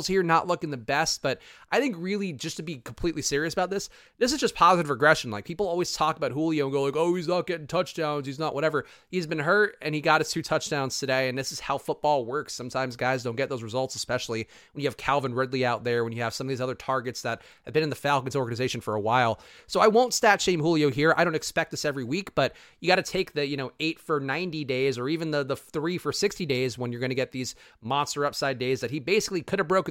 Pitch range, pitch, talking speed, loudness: 130-170 Hz, 150 Hz, 265 wpm, -27 LUFS